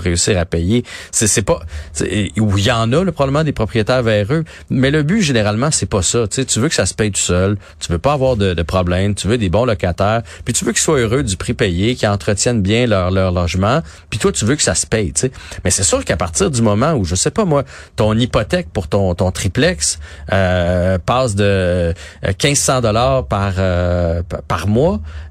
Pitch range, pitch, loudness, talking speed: 90-125 Hz, 105 Hz, -16 LUFS, 230 wpm